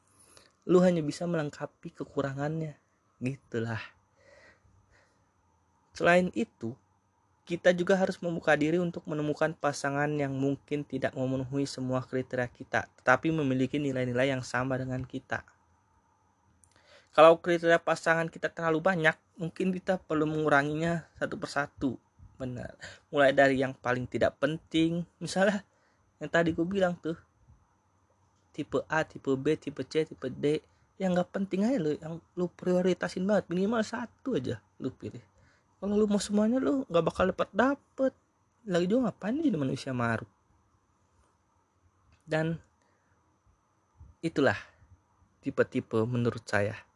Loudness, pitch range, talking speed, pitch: -30 LUFS, 110-170 Hz, 125 wpm, 140 Hz